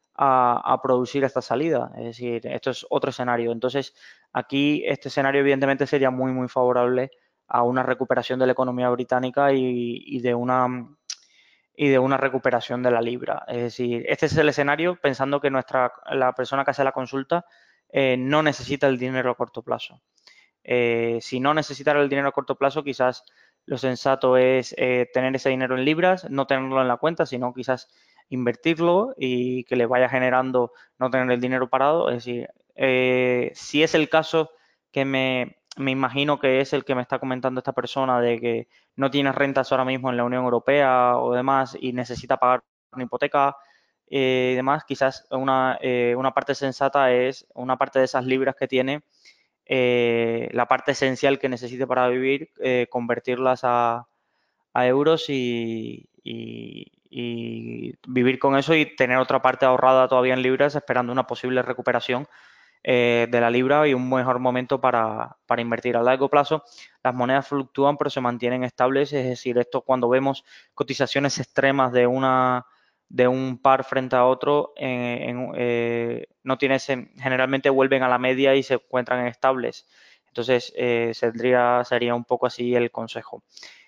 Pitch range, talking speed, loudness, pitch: 125-135 Hz, 175 wpm, -22 LUFS, 130 Hz